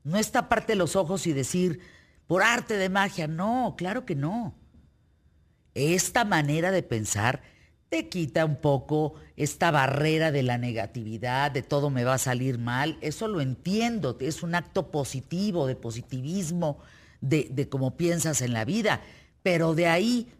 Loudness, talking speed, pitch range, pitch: -27 LUFS, 160 wpm, 135-185 Hz, 160 Hz